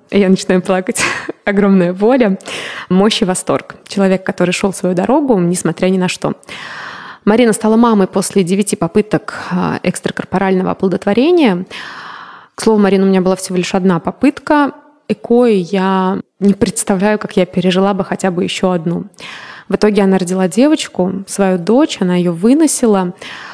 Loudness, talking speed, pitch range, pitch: -13 LUFS, 150 wpm, 185-220 Hz, 195 Hz